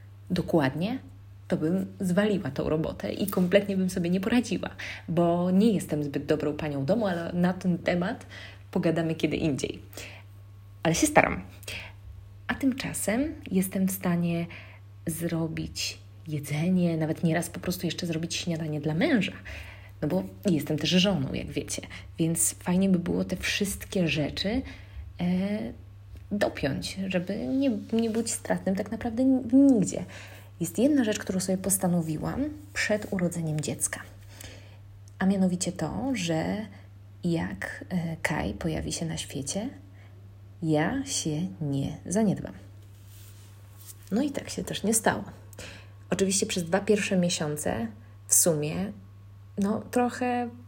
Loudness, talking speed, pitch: -28 LUFS, 130 wpm, 160 Hz